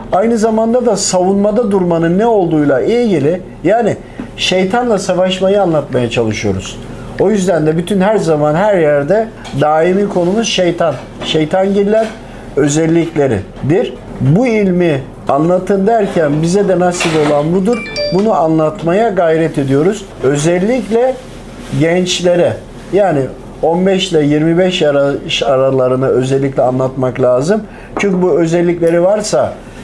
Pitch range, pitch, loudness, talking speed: 145-200 Hz, 175 Hz, -12 LUFS, 110 wpm